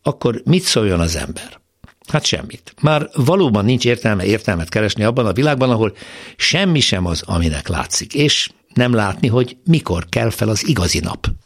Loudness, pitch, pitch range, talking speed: -16 LUFS, 115 Hz, 95-140 Hz, 170 wpm